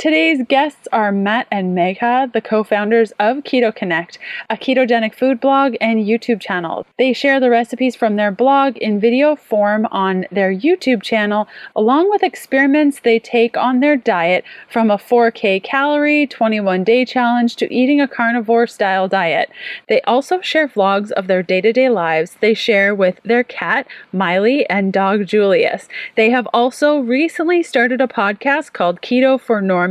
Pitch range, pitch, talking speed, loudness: 205-265 Hz, 235 Hz, 160 wpm, -15 LUFS